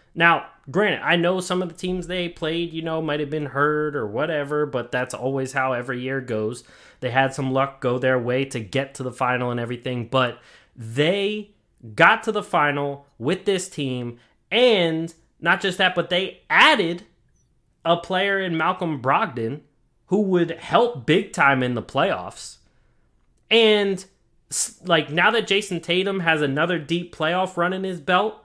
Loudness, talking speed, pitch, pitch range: -22 LUFS, 175 wpm, 160 Hz, 130-180 Hz